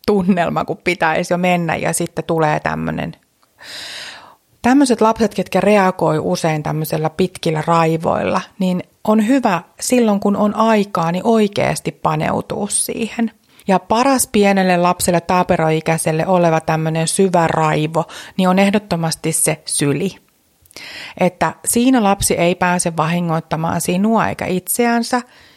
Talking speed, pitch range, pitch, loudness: 120 wpm, 160-210 Hz, 180 Hz, -16 LUFS